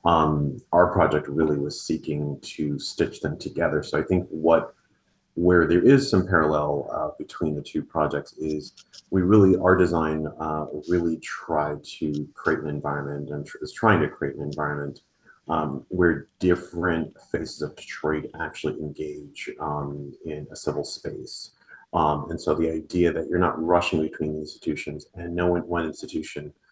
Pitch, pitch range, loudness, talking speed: 75 Hz, 75-85 Hz, -25 LUFS, 165 wpm